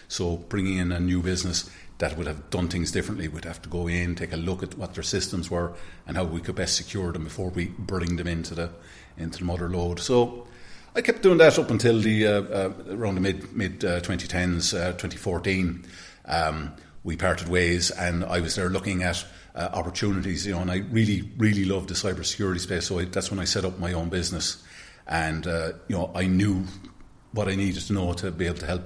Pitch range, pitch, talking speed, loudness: 85-95 Hz, 90 Hz, 225 wpm, -26 LUFS